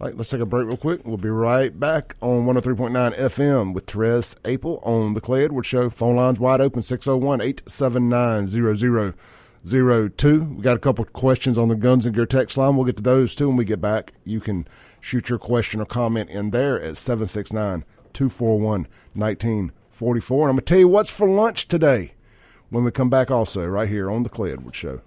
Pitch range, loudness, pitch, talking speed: 110-130 Hz, -21 LUFS, 120 Hz, 195 wpm